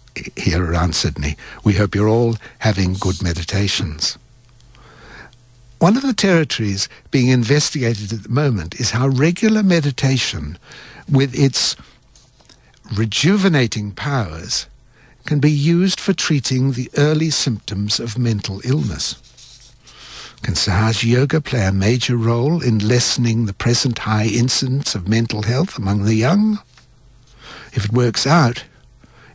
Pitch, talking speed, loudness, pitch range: 120 Hz, 125 wpm, -17 LUFS, 105-140 Hz